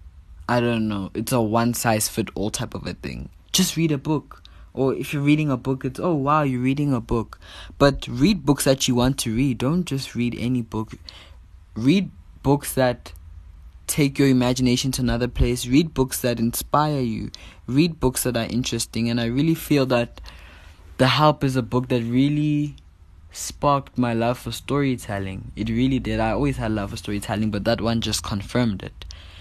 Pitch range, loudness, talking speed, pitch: 105-135 Hz, -22 LUFS, 190 wpm, 120 Hz